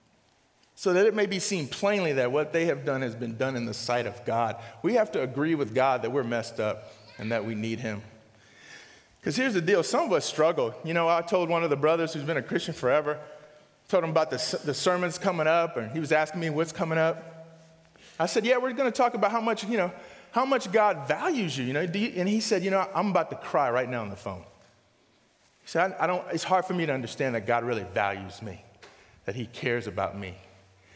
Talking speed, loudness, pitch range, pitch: 250 wpm, -27 LUFS, 120-180 Hz, 155 Hz